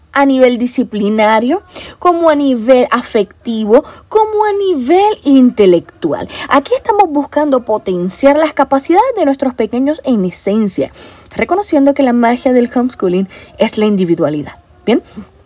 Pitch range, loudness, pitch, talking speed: 215-300 Hz, -12 LUFS, 255 Hz, 125 wpm